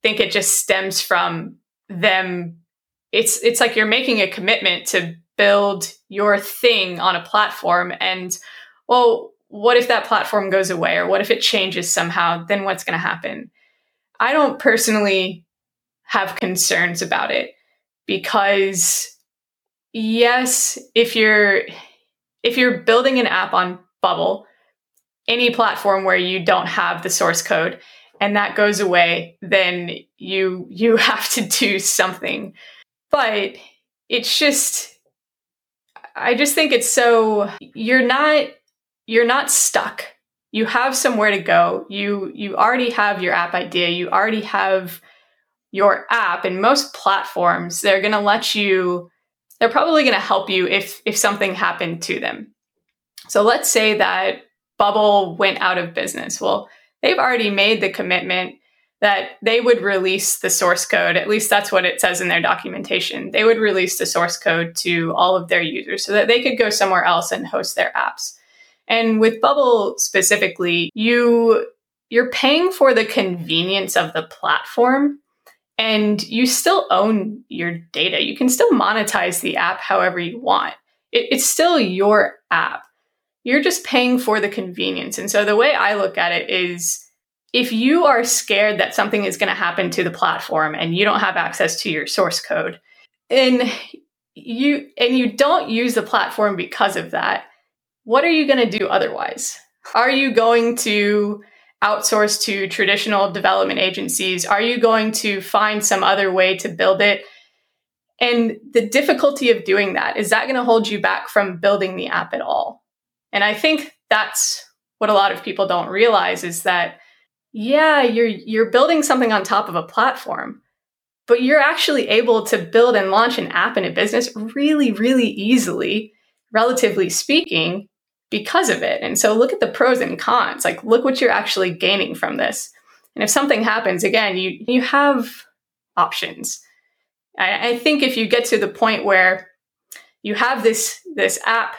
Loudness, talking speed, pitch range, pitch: -17 LUFS, 165 wpm, 195-245 Hz, 215 Hz